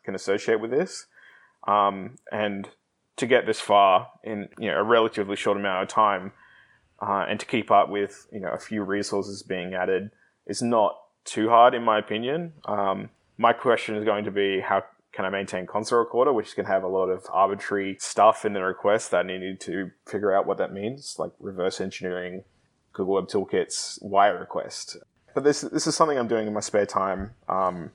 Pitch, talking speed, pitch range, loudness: 100 Hz, 200 wpm, 95-105 Hz, -25 LUFS